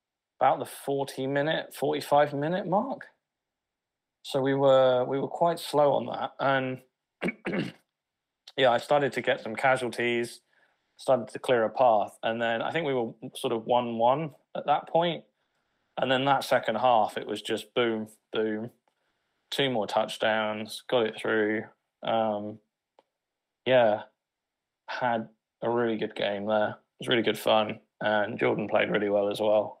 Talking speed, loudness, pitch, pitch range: 150 wpm, -27 LUFS, 120 Hz, 110-135 Hz